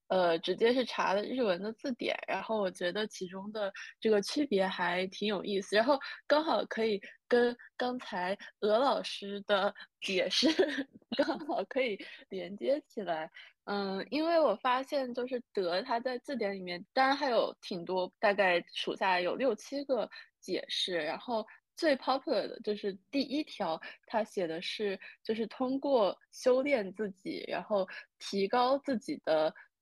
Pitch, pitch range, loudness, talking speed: 220 Hz, 195-270 Hz, -33 LUFS, 235 characters per minute